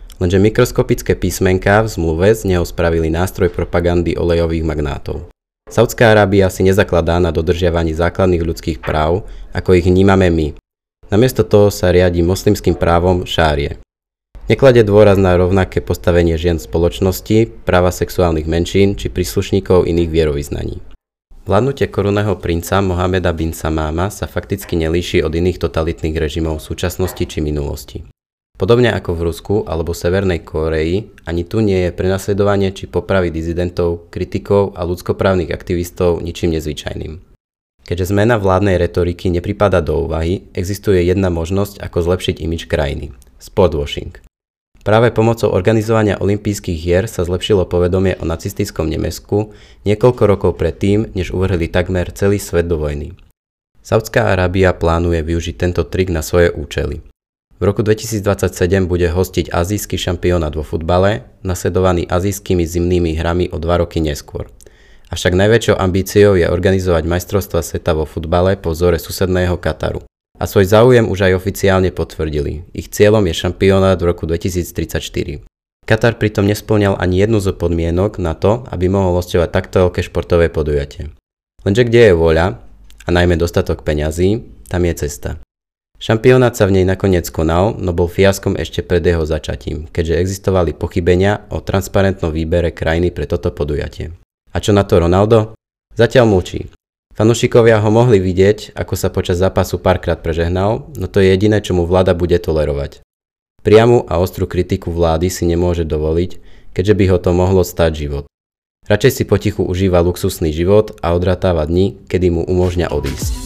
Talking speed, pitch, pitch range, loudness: 145 wpm, 90 Hz, 85-100 Hz, -15 LUFS